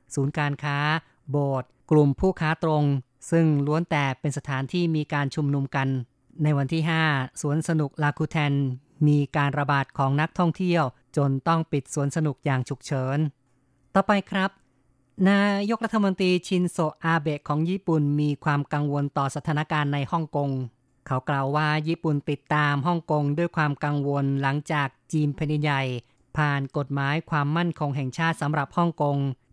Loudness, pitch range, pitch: -25 LUFS, 140-160 Hz, 145 Hz